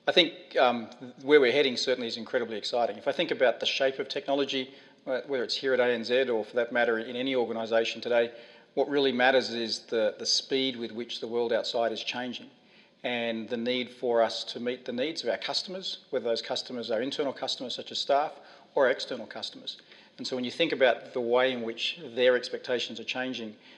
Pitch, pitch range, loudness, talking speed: 125 Hz, 115-130 Hz, -29 LUFS, 210 wpm